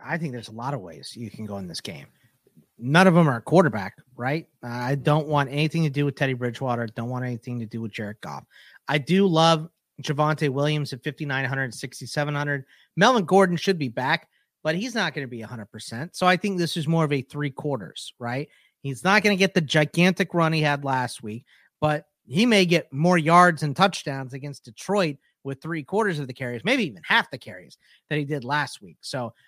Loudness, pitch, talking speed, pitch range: -23 LUFS, 150 Hz, 215 wpm, 130-170 Hz